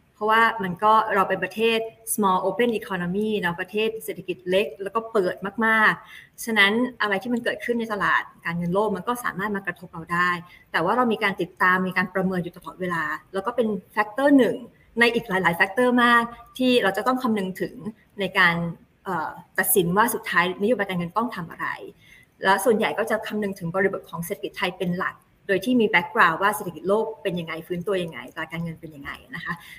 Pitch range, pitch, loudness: 180-220 Hz, 200 Hz, -23 LUFS